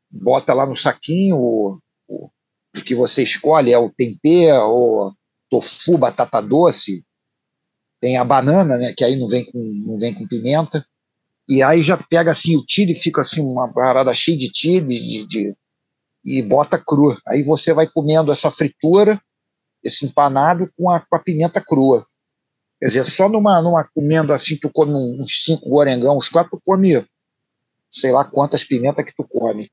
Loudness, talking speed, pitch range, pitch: -16 LUFS, 175 wpm, 130-170 Hz, 150 Hz